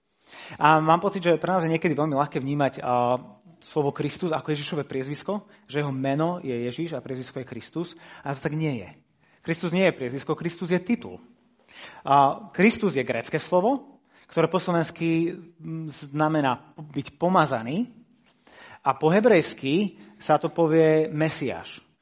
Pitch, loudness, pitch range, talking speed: 160 Hz, -25 LUFS, 140-175 Hz, 145 wpm